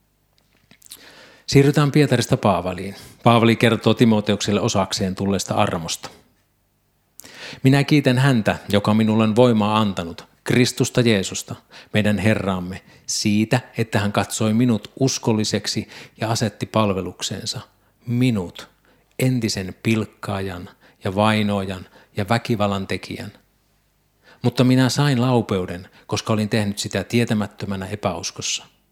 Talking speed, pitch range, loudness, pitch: 100 wpm, 100-120 Hz, -20 LUFS, 110 Hz